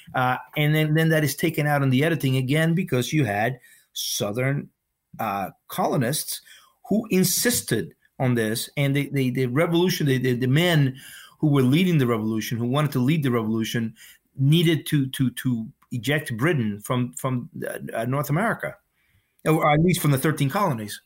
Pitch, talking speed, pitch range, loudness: 140 Hz, 170 wpm, 125-155 Hz, -23 LUFS